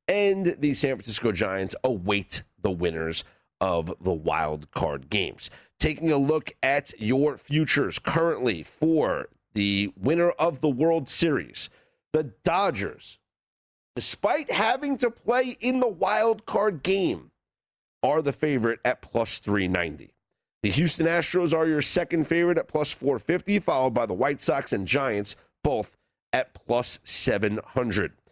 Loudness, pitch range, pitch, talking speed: -26 LUFS, 105-170 Hz, 145 Hz, 140 wpm